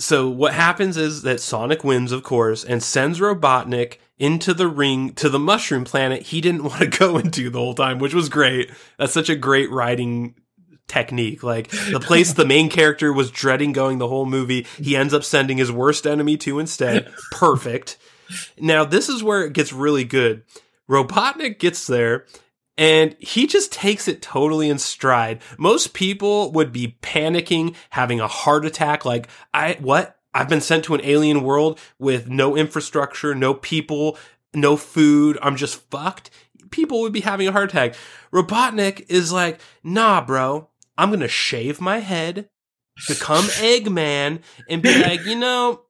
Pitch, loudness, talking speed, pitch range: 150 Hz, -19 LUFS, 175 wpm, 130-175 Hz